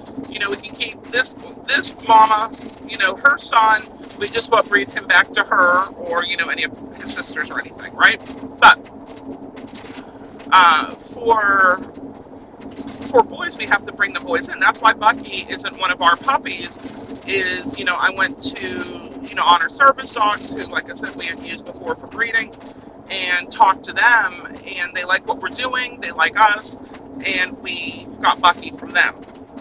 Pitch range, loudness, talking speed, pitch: 205-255 Hz, -17 LUFS, 180 wpm, 225 Hz